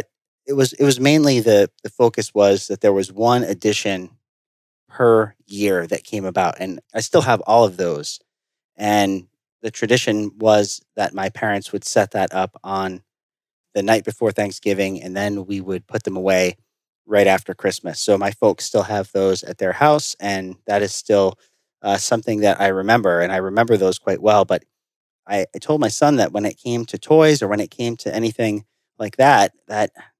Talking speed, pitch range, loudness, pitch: 195 wpm, 95-115 Hz, -18 LUFS, 105 Hz